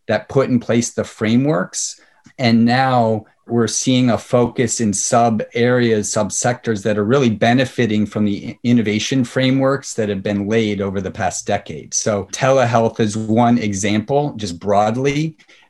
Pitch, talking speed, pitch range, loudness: 115 Hz, 155 wpm, 105-125 Hz, -17 LUFS